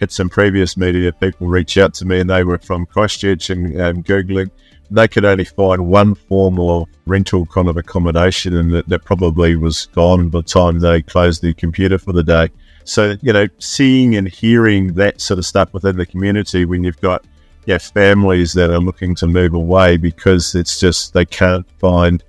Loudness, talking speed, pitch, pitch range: -14 LUFS, 200 wpm, 90 Hz, 85-95 Hz